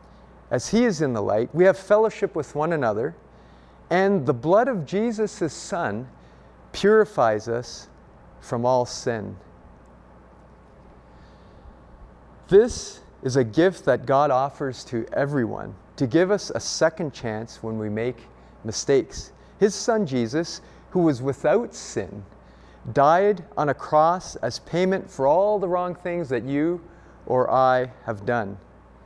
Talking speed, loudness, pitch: 140 wpm, -23 LUFS, 130 Hz